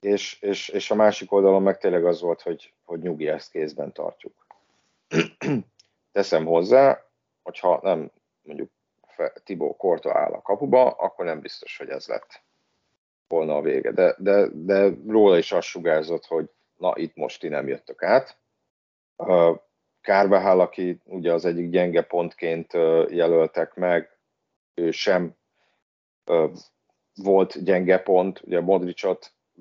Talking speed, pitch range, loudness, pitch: 135 wpm, 85-105 Hz, -22 LUFS, 95 Hz